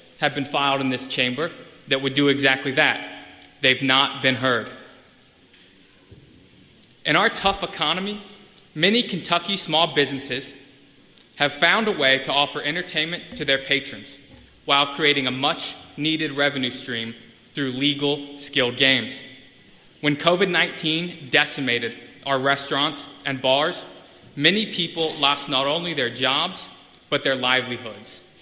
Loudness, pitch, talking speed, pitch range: -21 LUFS, 140 Hz, 130 wpm, 130-155 Hz